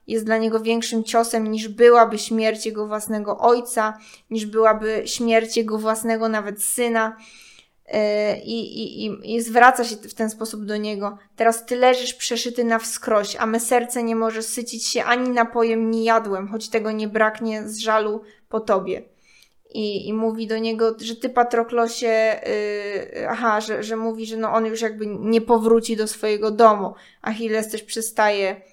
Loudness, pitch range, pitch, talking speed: -21 LUFS, 215-230 Hz, 225 Hz, 165 wpm